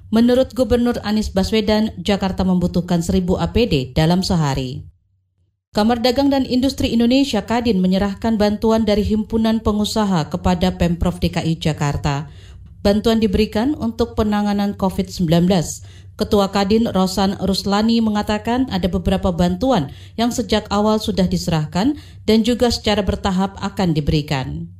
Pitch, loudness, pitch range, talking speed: 200 Hz, -18 LUFS, 175-225 Hz, 120 wpm